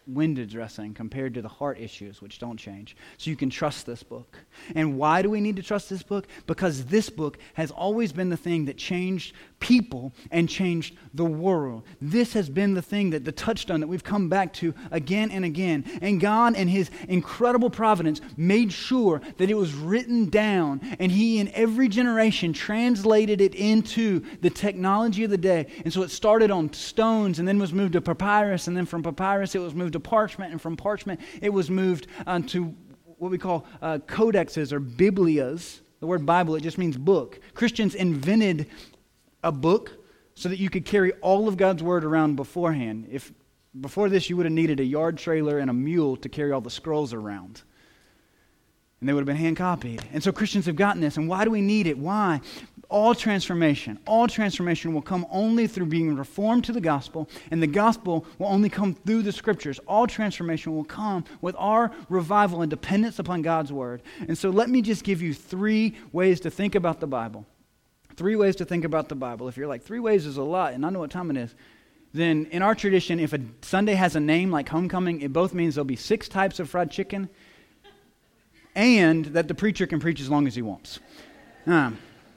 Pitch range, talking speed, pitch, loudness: 155-205 Hz, 205 wpm, 180 Hz, -25 LUFS